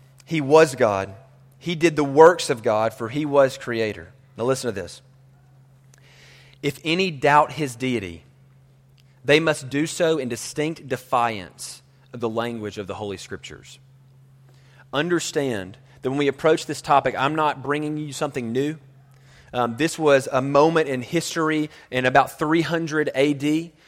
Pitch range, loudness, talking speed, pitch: 130-150 Hz, -22 LUFS, 150 wpm, 135 Hz